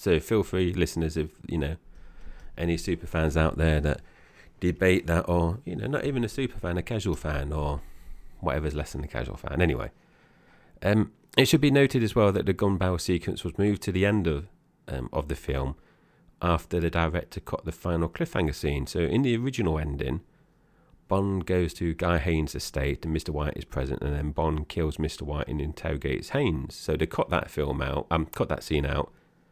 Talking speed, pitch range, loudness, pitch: 205 wpm, 75-95 Hz, -28 LUFS, 85 Hz